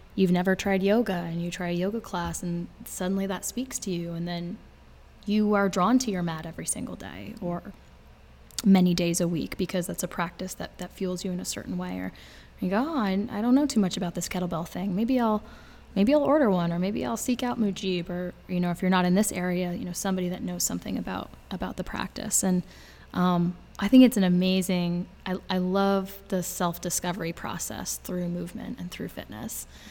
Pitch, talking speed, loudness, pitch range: 185 Hz, 215 wpm, -27 LUFS, 175-205 Hz